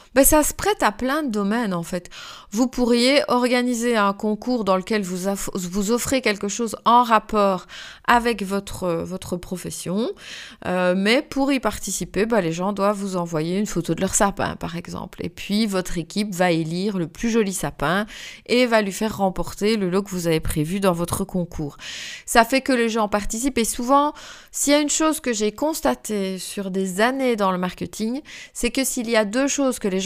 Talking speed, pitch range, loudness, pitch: 205 wpm, 185-245 Hz, -22 LUFS, 210 Hz